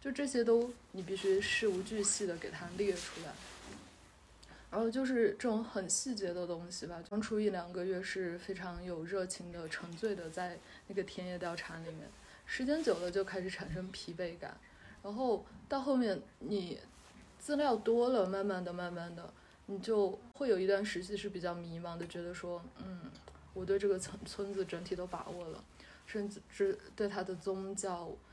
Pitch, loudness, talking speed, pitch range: 195 Hz, -37 LUFS, 255 characters per minute, 175-210 Hz